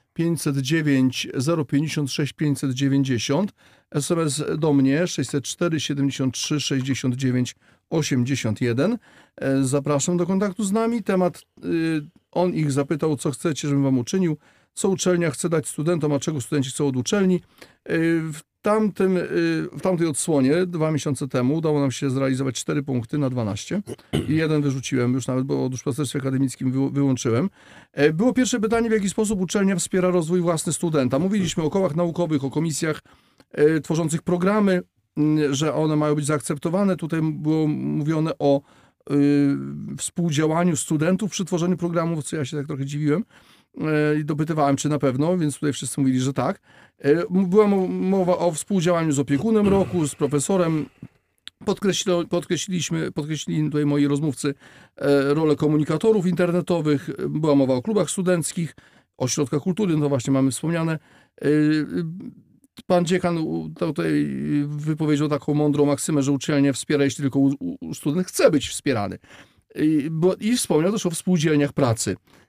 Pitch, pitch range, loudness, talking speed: 155 Hz, 140-175 Hz, -22 LUFS, 135 wpm